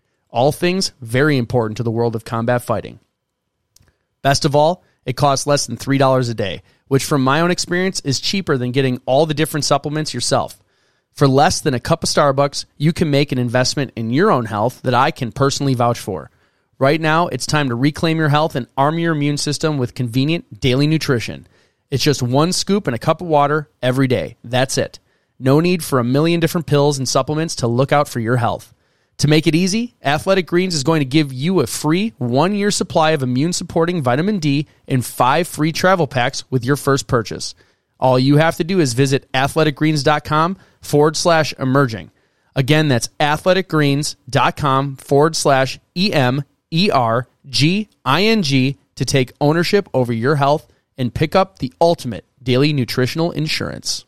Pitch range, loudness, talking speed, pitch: 125-160 Hz, -17 LUFS, 190 wpm, 140 Hz